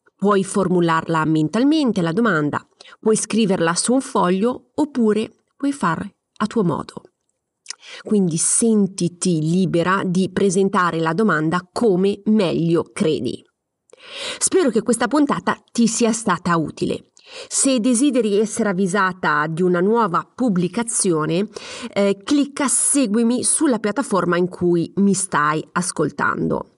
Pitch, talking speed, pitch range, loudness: 200 Hz, 115 wpm, 175-235 Hz, -19 LUFS